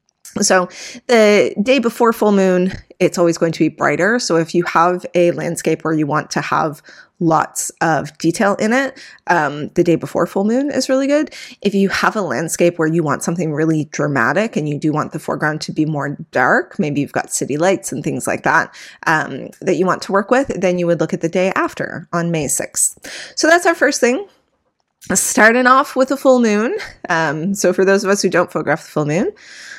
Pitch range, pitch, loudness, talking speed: 165-235 Hz, 185 Hz, -16 LUFS, 220 wpm